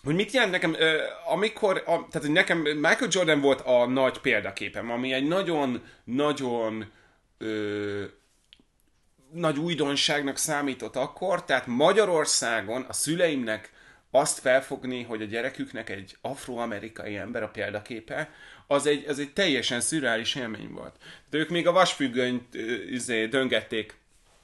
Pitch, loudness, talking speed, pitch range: 135 Hz, -26 LUFS, 125 wpm, 120-160 Hz